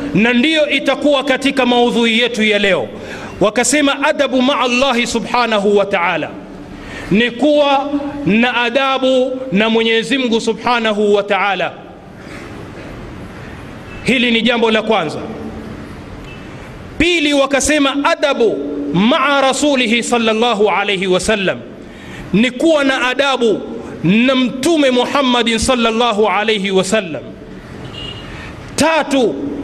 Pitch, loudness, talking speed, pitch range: 245 Hz, -13 LUFS, 100 wpm, 220-275 Hz